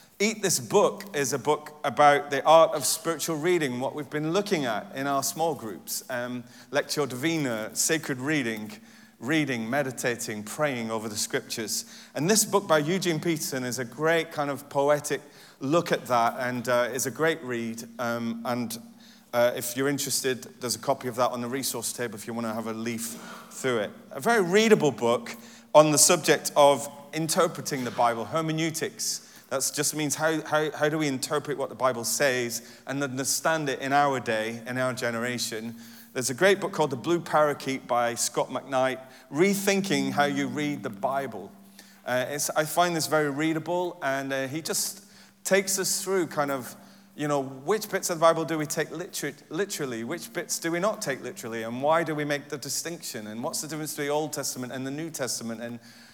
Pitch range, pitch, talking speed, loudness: 125-160 Hz, 145 Hz, 195 wpm, -27 LUFS